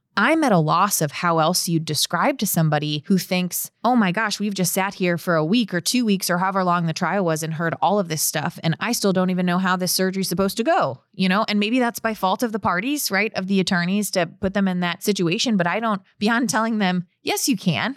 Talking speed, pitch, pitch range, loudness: 265 wpm, 190 Hz, 175-215 Hz, -21 LUFS